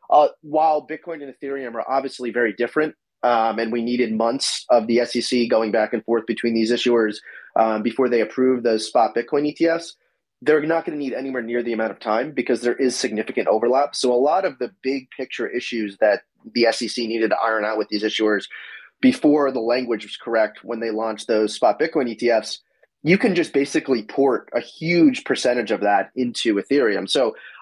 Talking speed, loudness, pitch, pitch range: 200 wpm, -21 LUFS, 120 Hz, 115-140 Hz